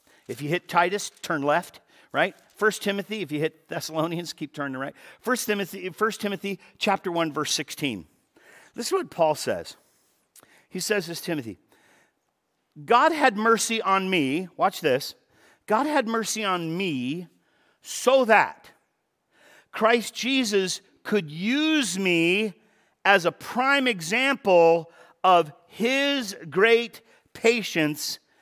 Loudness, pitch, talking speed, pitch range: -24 LUFS, 195 Hz, 125 wpm, 170-230 Hz